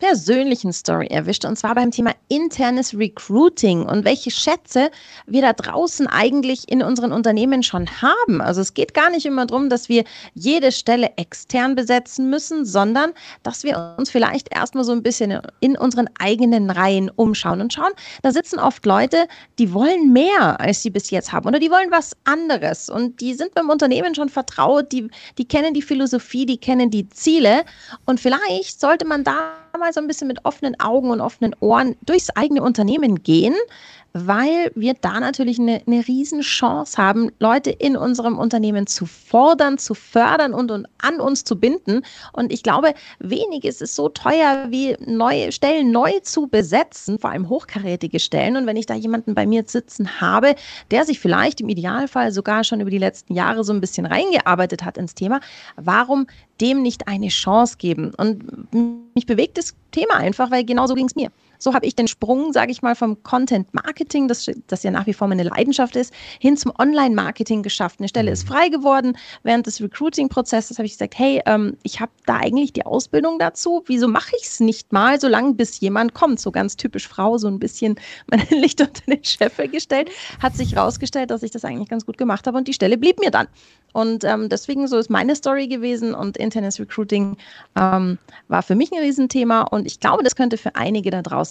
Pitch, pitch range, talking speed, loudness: 245 Hz, 220-275 Hz, 195 wpm, -18 LUFS